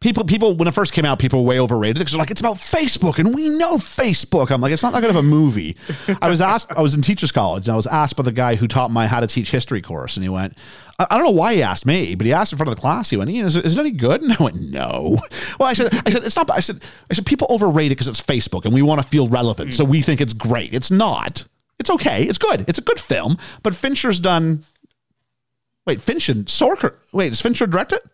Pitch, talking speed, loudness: 160 Hz, 280 wpm, -18 LUFS